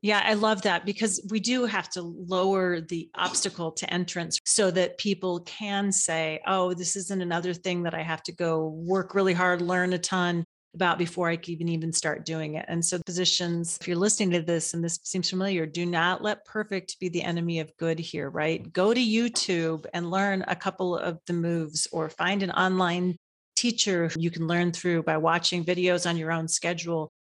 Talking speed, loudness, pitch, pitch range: 205 wpm, -27 LUFS, 175 Hz, 170-190 Hz